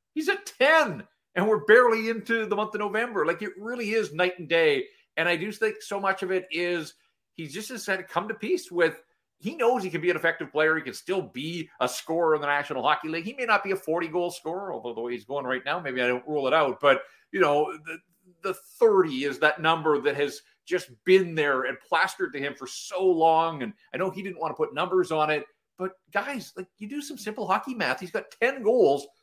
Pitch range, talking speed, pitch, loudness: 160-215 Hz, 245 wpm, 180 Hz, -26 LUFS